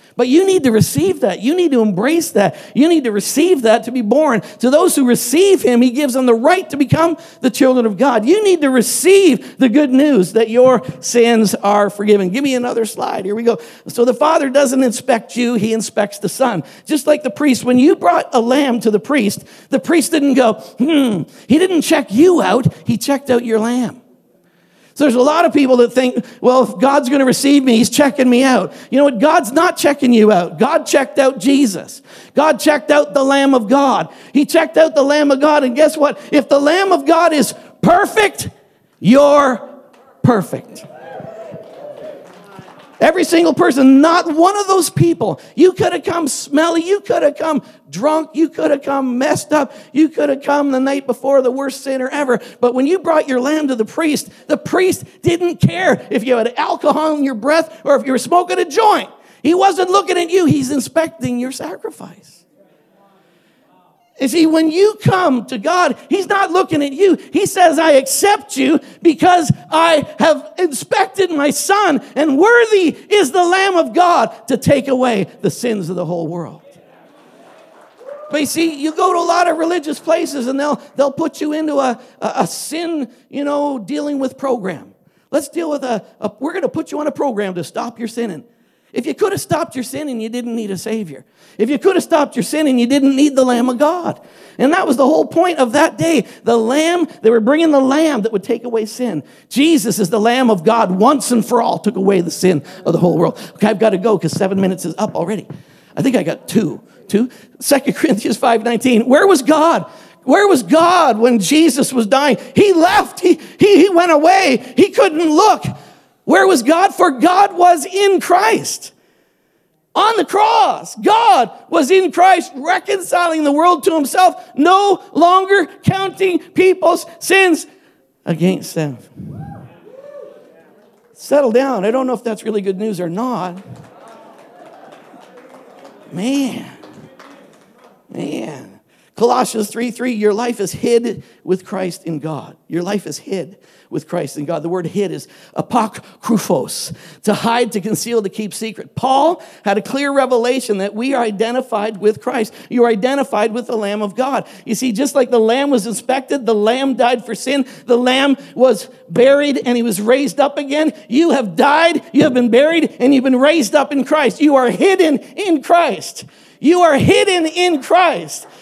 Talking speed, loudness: 195 wpm, -14 LUFS